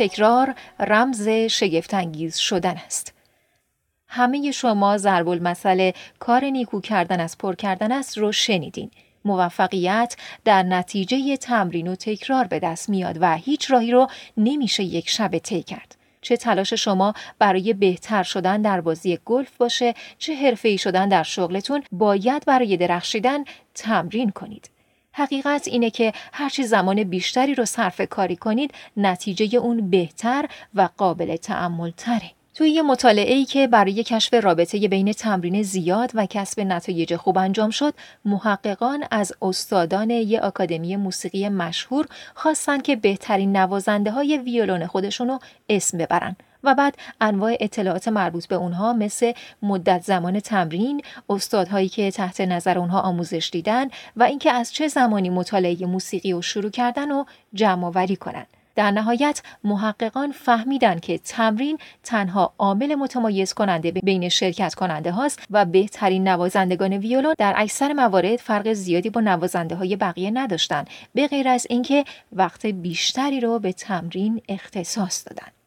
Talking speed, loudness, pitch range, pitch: 140 wpm, -21 LUFS, 185-245 Hz, 205 Hz